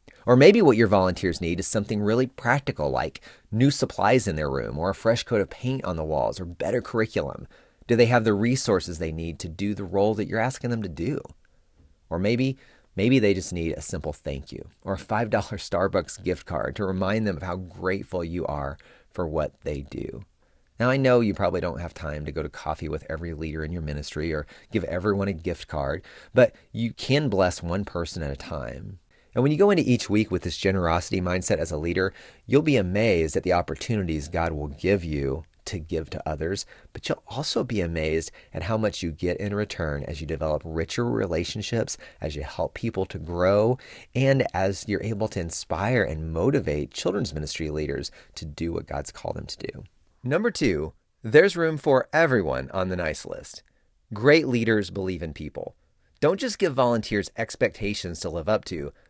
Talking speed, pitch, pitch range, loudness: 205 wpm, 95 Hz, 80-110 Hz, -25 LUFS